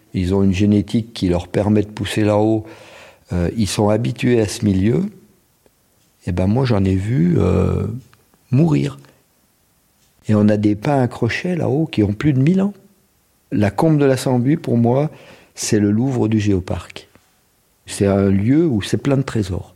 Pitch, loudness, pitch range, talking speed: 110 Hz, -18 LUFS, 100-135 Hz, 175 wpm